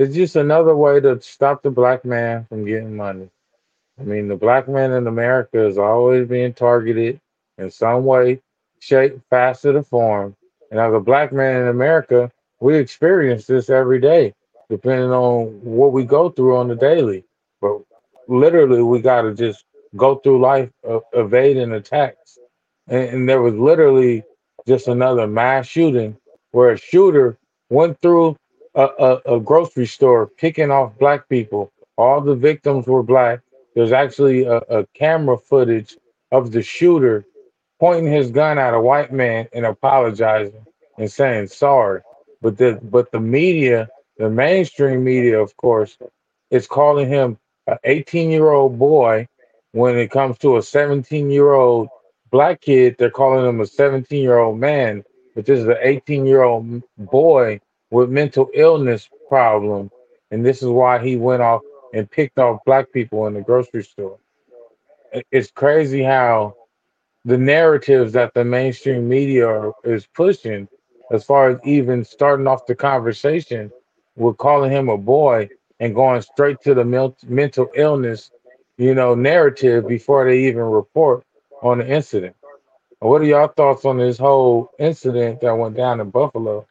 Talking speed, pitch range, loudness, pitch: 160 wpm, 120-140 Hz, -16 LUFS, 125 Hz